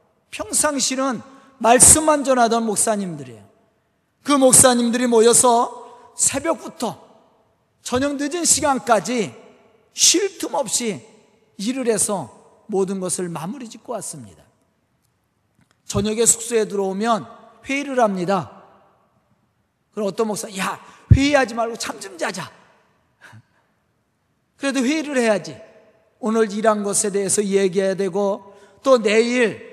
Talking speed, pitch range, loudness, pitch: 240 characters per minute, 205-260 Hz, -18 LUFS, 225 Hz